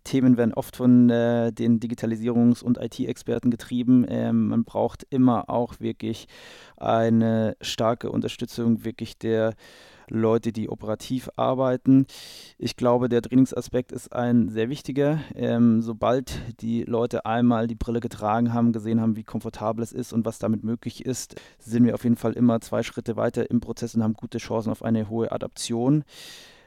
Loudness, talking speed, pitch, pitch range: -24 LUFS, 160 wpm, 115 Hz, 115-120 Hz